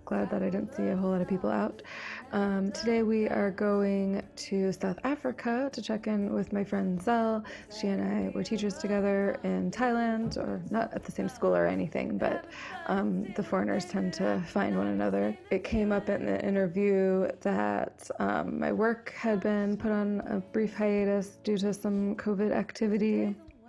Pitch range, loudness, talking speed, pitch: 190-215 Hz, -30 LUFS, 185 wpm, 200 Hz